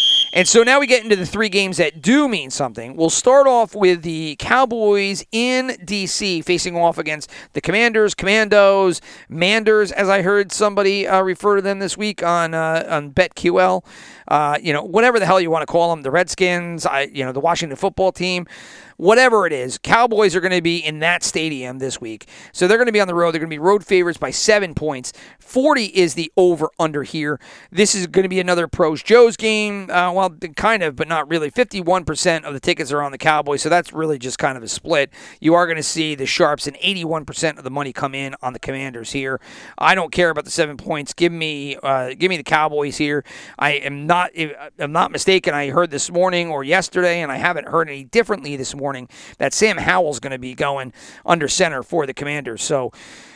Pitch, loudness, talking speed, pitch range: 170 Hz, -17 LUFS, 220 wpm, 145-195 Hz